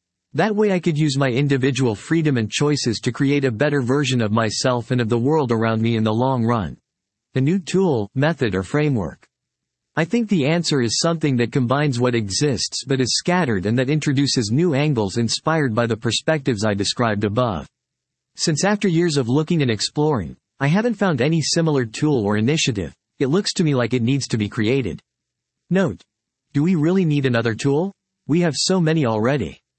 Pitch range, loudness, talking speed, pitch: 115-155 Hz, -20 LUFS, 190 wpm, 135 Hz